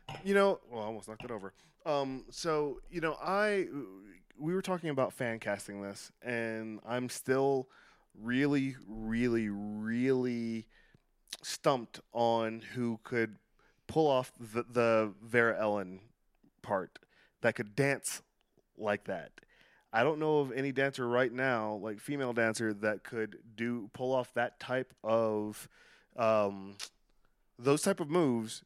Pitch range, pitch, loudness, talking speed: 110-135 Hz, 120 Hz, -34 LUFS, 140 wpm